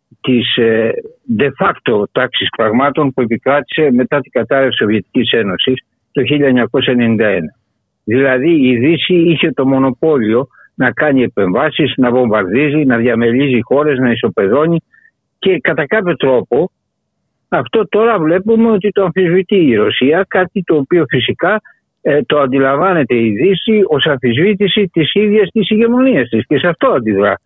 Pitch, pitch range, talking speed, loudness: 145 Hz, 125-195 Hz, 140 wpm, -12 LUFS